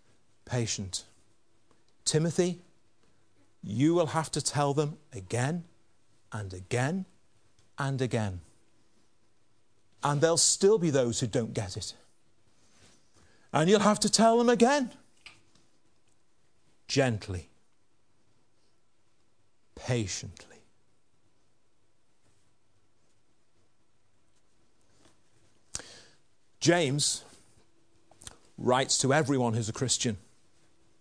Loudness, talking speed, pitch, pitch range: -28 LUFS, 75 wpm, 115 Hz, 110-145 Hz